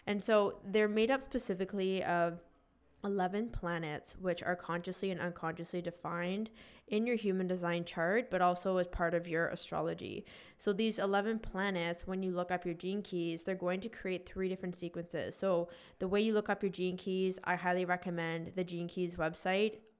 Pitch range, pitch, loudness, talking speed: 175-200 Hz, 185 Hz, -36 LUFS, 185 wpm